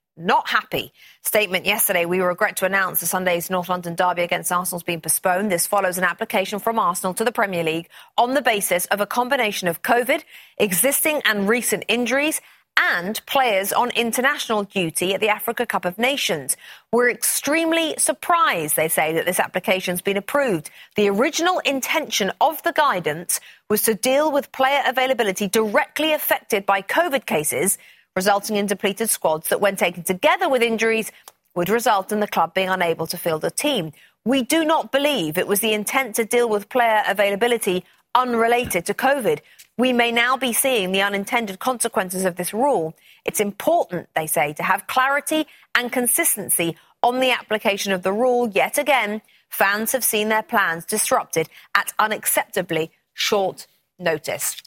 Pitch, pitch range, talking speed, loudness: 215 Hz, 185-260 Hz, 170 wpm, -20 LUFS